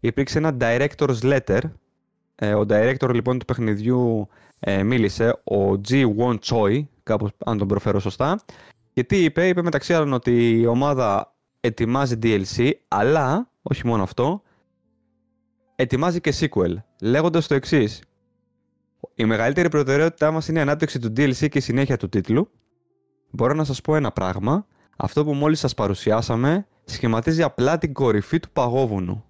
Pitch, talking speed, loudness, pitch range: 130 Hz, 150 wpm, -21 LUFS, 115-155 Hz